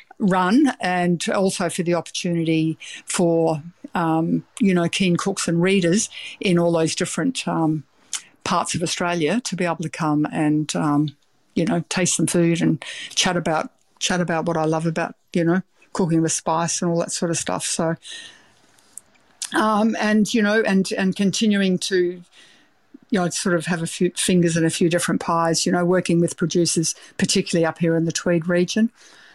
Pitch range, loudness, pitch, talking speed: 165-195 Hz, -21 LUFS, 175 Hz, 180 wpm